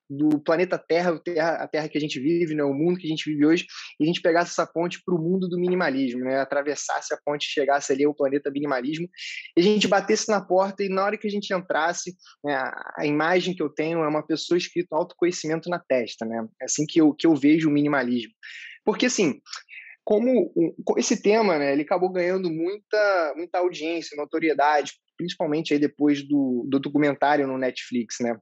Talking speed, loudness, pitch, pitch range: 200 wpm, -24 LUFS, 160 Hz, 145-180 Hz